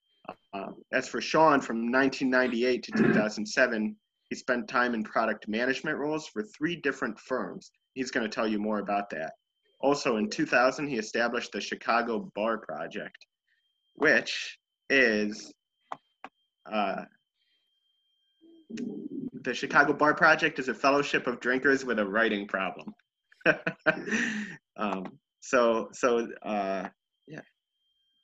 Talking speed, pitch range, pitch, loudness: 120 wpm, 105-150 Hz, 125 Hz, -28 LUFS